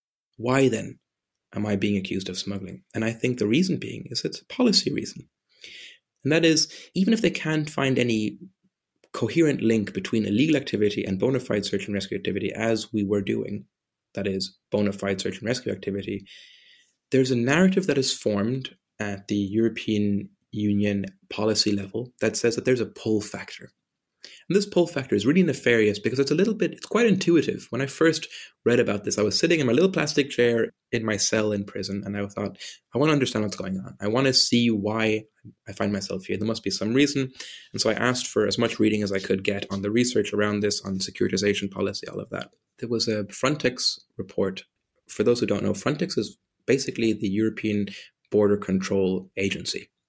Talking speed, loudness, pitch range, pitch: 205 wpm, -25 LUFS, 100-130 Hz, 110 Hz